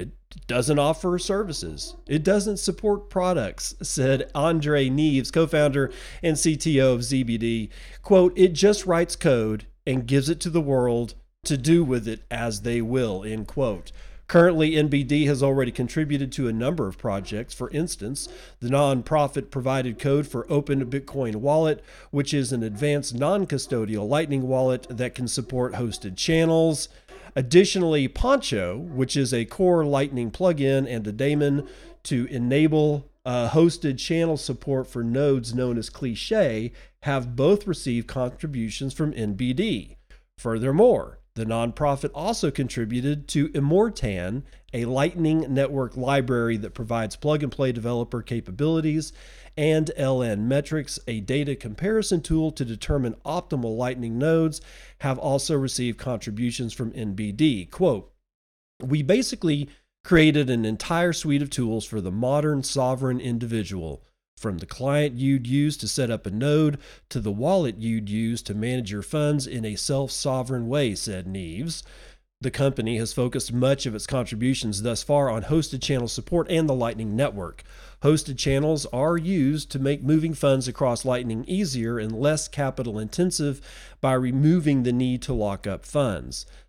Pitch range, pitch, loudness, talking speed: 120-150 Hz, 135 Hz, -24 LUFS, 150 wpm